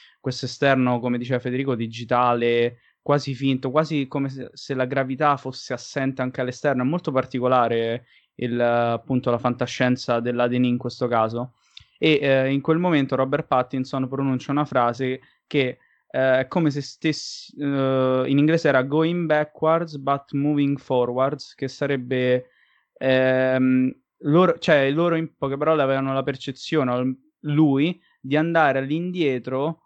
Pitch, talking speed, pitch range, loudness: 135 Hz, 140 wpm, 125-145 Hz, -22 LUFS